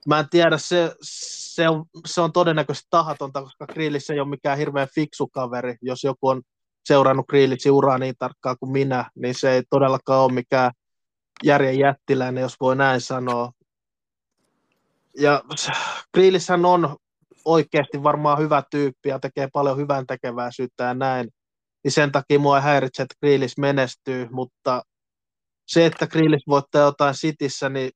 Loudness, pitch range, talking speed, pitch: -21 LUFS, 130-150 Hz, 150 wpm, 140 Hz